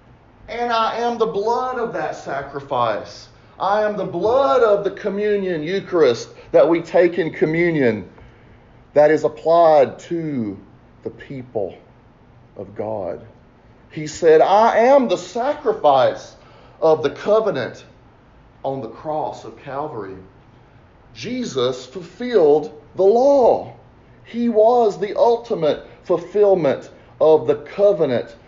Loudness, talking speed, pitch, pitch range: -18 LUFS, 115 wpm, 175 Hz, 140-210 Hz